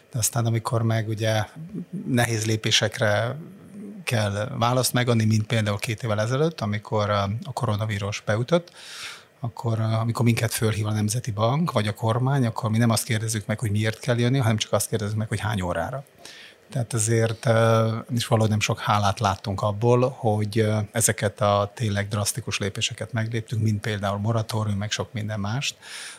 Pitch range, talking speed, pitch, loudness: 105-120 Hz, 160 wpm, 110 Hz, -24 LUFS